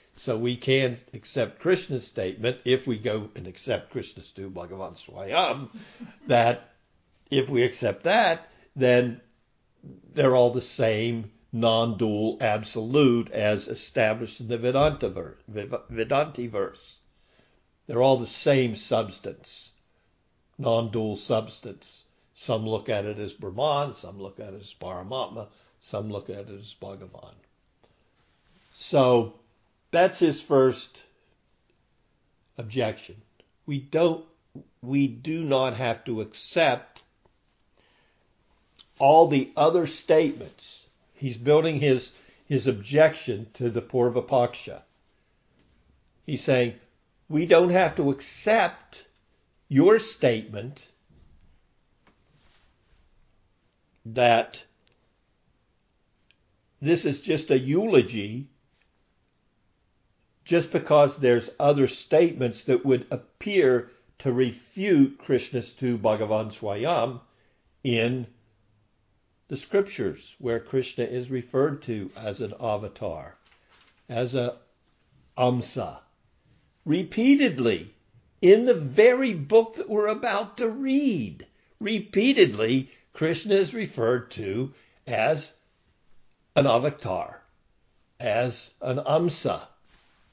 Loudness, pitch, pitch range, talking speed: -25 LUFS, 125 Hz, 110-145 Hz, 100 wpm